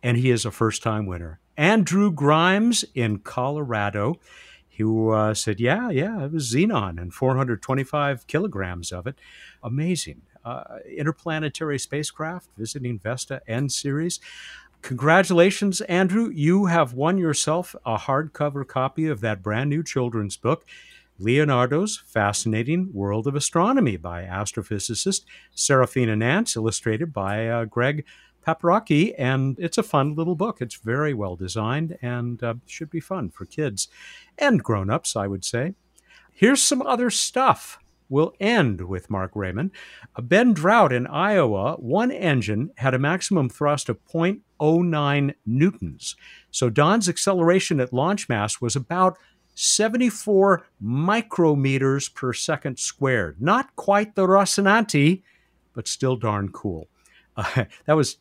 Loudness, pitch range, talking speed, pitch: -22 LUFS, 115-175 Hz, 135 wpm, 140 Hz